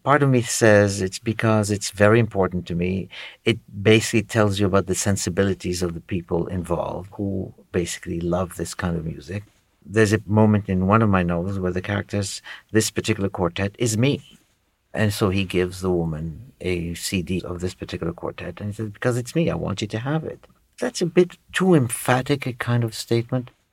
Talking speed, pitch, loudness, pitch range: 195 wpm, 100 Hz, -22 LUFS, 90-115 Hz